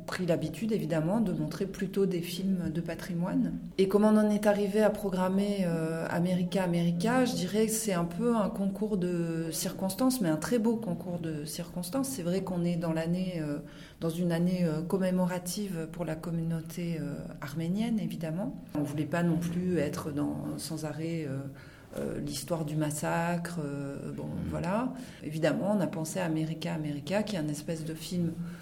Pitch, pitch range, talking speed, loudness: 170 Hz, 160-190 Hz, 180 wpm, -31 LUFS